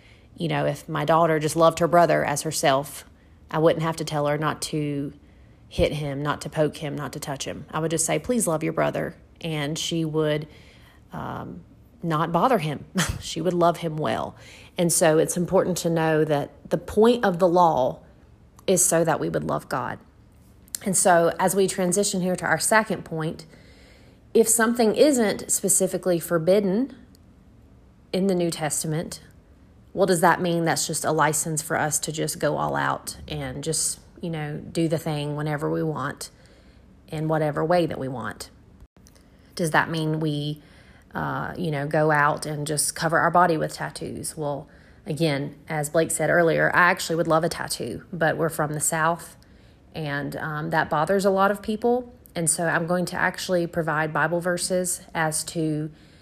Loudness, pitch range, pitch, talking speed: -23 LUFS, 150-175 Hz, 160 Hz, 180 wpm